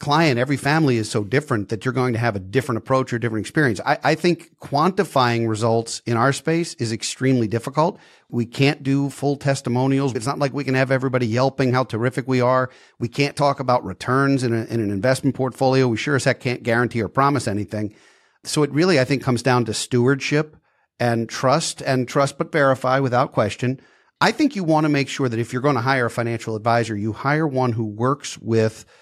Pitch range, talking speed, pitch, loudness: 120-140 Hz, 215 wpm, 130 Hz, -21 LUFS